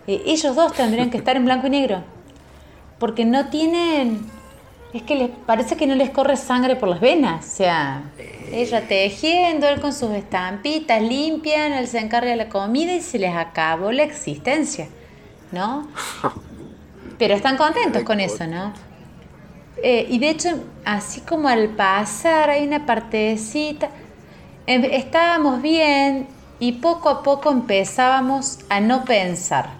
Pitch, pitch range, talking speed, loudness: 255 Hz, 210-295 Hz, 150 wpm, -19 LUFS